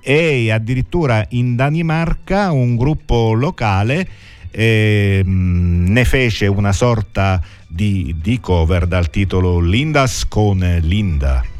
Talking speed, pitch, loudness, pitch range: 105 wpm, 105 Hz, -16 LUFS, 95-125 Hz